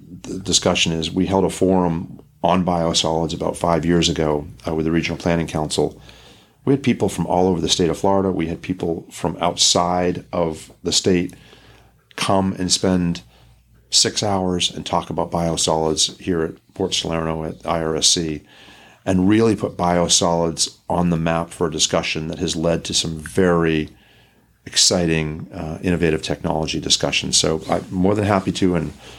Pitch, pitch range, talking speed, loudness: 85 Hz, 80-90 Hz, 165 wpm, -19 LUFS